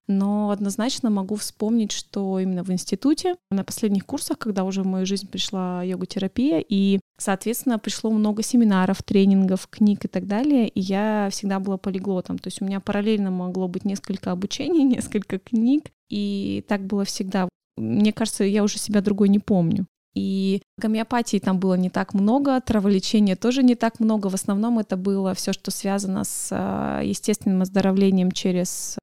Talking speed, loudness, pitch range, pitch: 165 wpm, -23 LUFS, 190-220 Hz, 200 Hz